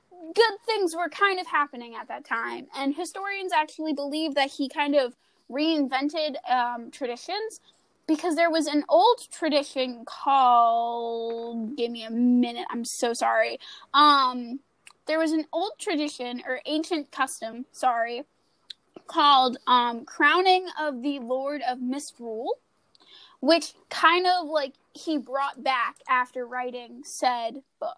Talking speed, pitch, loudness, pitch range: 135 wpm, 290 Hz, -25 LUFS, 250-330 Hz